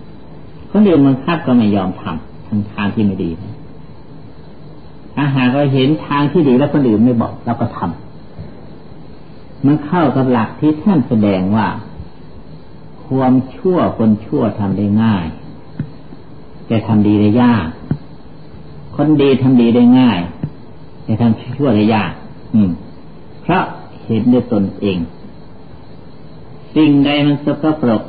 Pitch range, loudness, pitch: 105-145 Hz, -14 LUFS, 120 Hz